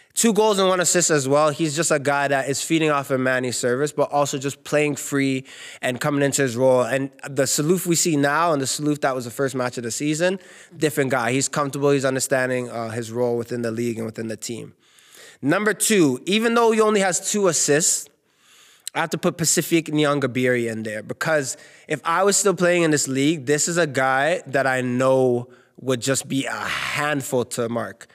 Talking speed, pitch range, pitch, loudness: 215 wpm, 130-160 Hz, 140 Hz, -21 LUFS